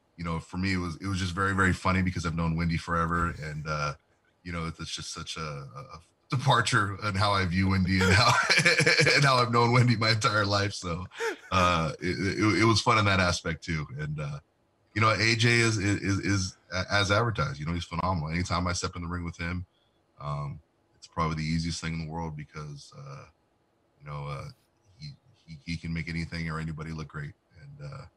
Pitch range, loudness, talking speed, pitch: 85-115 Hz, -27 LUFS, 215 wpm, 95 Hz